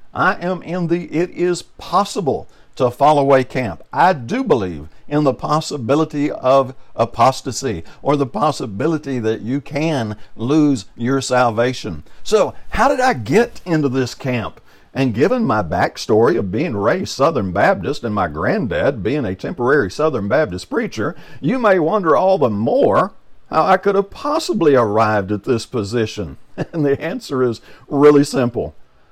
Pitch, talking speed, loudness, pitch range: 135 Hz, 155 wpm, -17 LUFS, 120-160 Hz